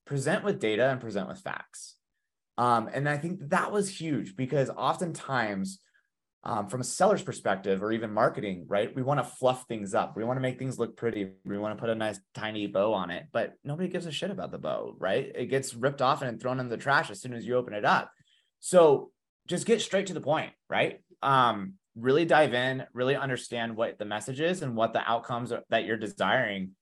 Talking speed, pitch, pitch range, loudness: 215 wpm, 125 Hz, 110-145 Hz, -29 LUFS